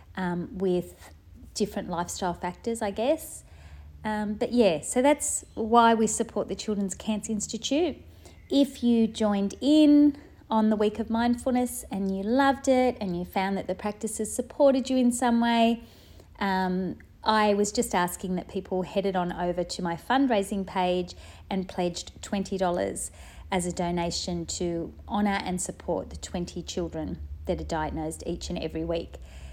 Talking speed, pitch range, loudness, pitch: 155 wpm, 175-230 Hz, -27 LUFS, 200 Hz